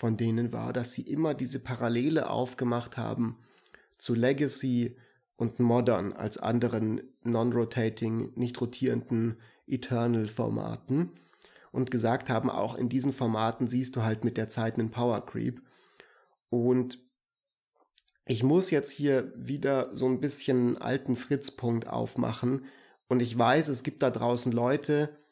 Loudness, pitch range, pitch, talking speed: -30 LUFS, 120-130 Hz, 125 Hz, 135 wpm